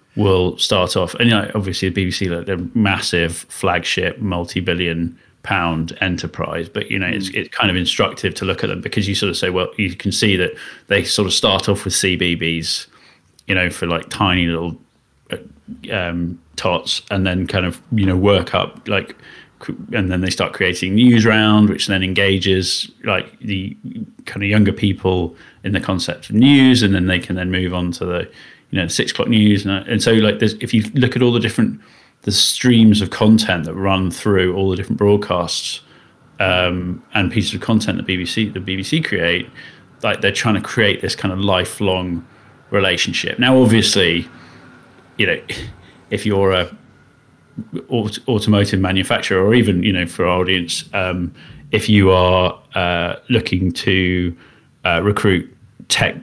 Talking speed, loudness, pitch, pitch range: 180 wpm, -17 LUFS, 95 Hz, 90-105 Hz